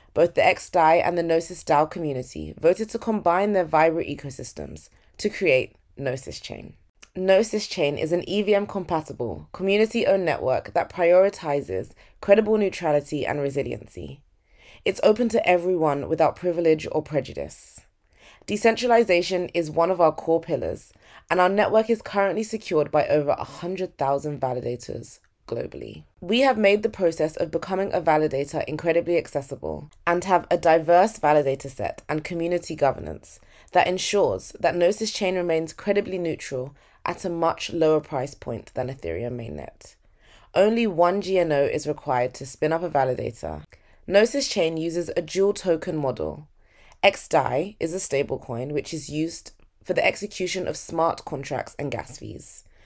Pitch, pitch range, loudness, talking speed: 165 Hz, 140-190 Hz, -23 LUFS, 145 wpm